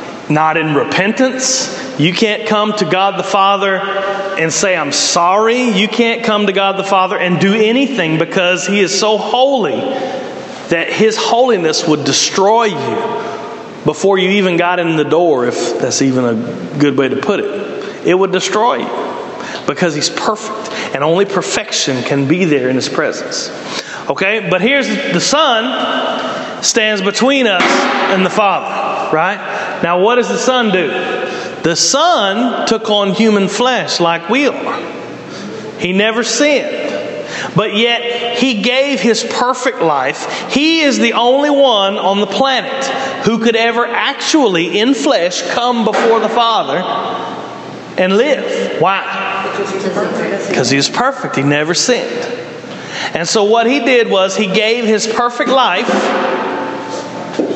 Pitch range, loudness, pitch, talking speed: 190-240 Hz, -13 LUFS, 215 Hz, 150 wpm